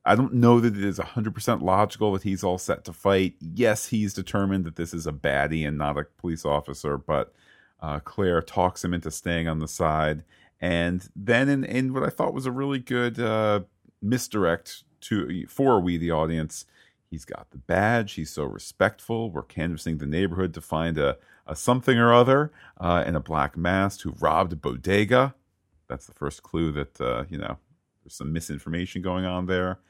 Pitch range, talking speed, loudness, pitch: 80-105 Hz, 195 wpm, -25 LUFS, 90 Hz